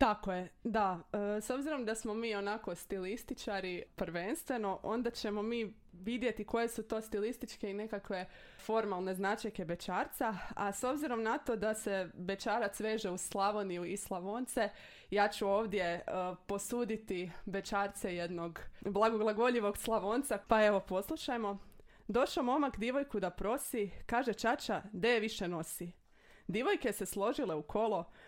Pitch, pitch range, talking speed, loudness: 210 Hz, 195-230 Hz, 140 wpm, -37 LUFS